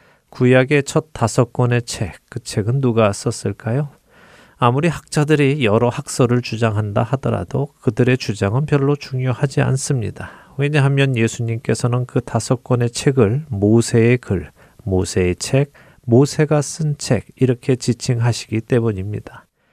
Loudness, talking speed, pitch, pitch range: -18 LUFS, 295 characters per minute, 125 Hz, 115-140 Hz